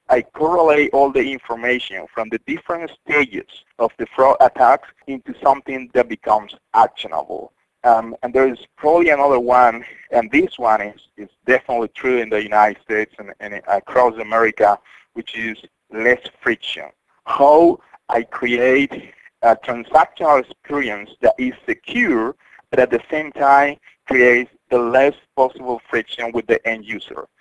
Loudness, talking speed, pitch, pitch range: -17 LUFS, 145 wpm, 125 Hz, 115-140 Hz